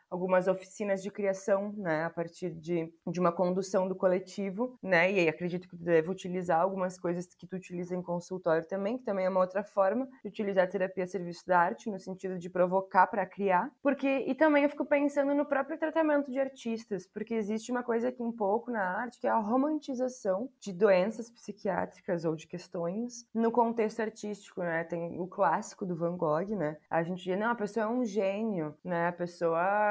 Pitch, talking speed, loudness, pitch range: 195 Hz, 205 wpm, -31 LUFS, 180-230 Hz